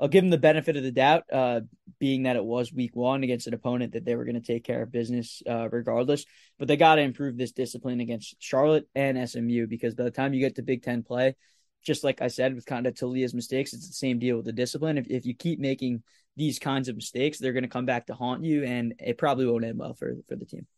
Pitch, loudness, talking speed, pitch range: 130 Hz, -27 LUFS, 270 wpm, 120-140 Hz